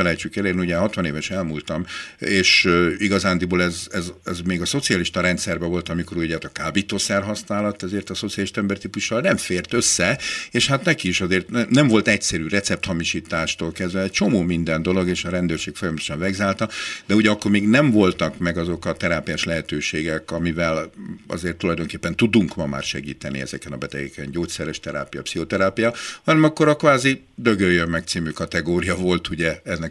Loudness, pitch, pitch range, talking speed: -21 LUFS, 90 Hz, 85-105 Hz, 165 wpm